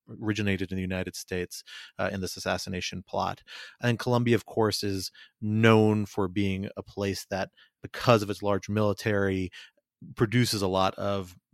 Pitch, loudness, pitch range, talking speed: 100 Hz, -28 LUFS, 95-110 Hz, 155 wpm